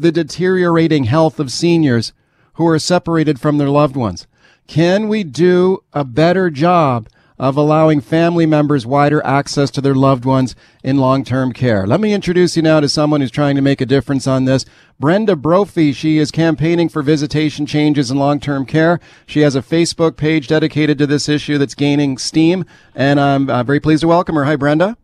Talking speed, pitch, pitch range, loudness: 190 wpm, 150 Hz, 140-165 Hz, -14 LUFS